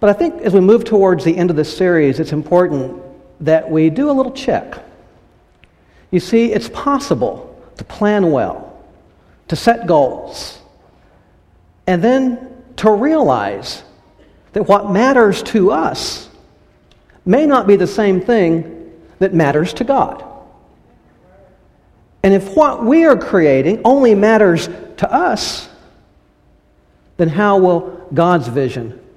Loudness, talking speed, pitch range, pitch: -14 LUFS, 130 wpm, 160-230 Hz, 195 Hz